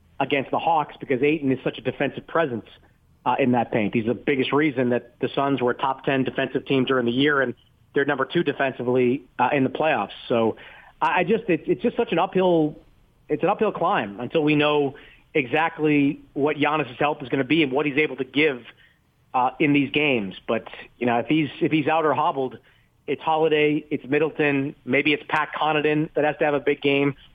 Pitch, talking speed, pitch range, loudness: 145 Hz, 215 wpm, 130-155 Hz, -23 LUFS